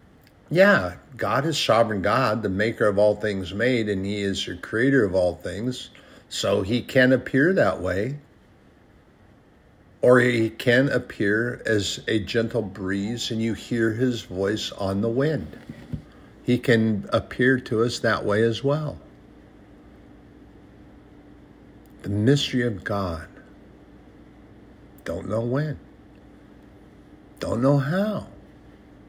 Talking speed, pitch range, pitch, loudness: 125 wpm, 100-125 Hz, 110 Hz, -23 LUFS